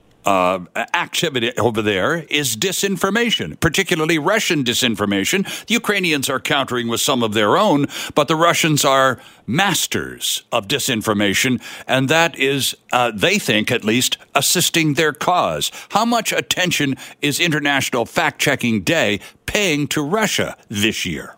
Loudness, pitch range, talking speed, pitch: -17 LUFS, 115-170 Hz, 140 wpm, 145 Hz